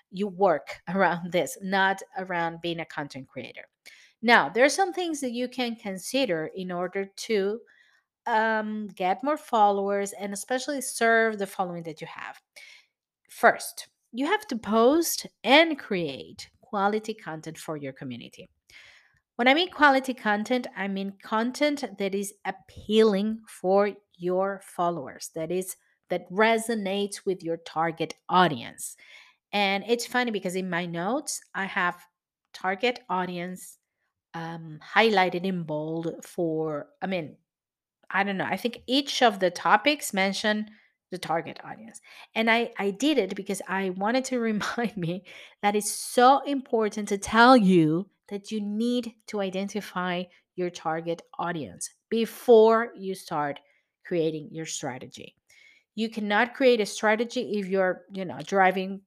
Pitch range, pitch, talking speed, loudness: 180-225 Hz, 200 Hz, 145 wpm, -26 LUFS